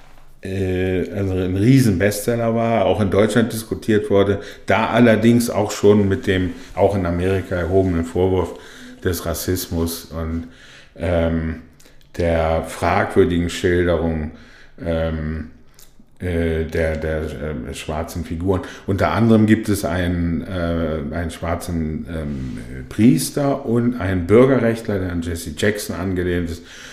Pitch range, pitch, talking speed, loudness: 85-100 Hz, 90 Hz, 120 wpm, -19 LUFS